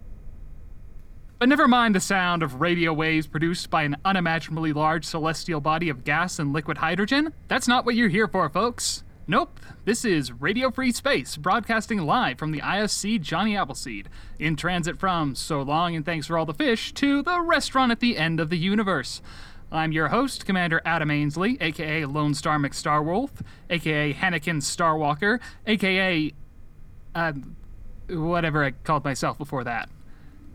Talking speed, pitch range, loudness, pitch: 155 wpm, 150-200 Hz, -24 LUFS, 165 Hz